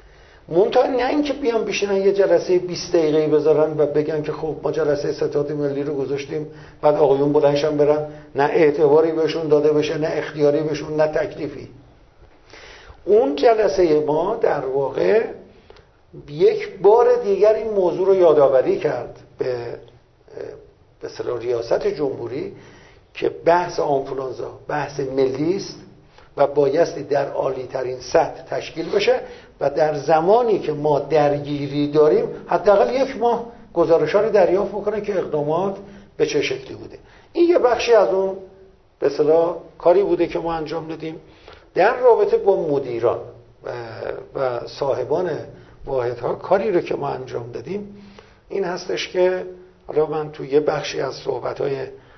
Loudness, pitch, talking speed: -19 LUFS, 185 Hz, 140 wpm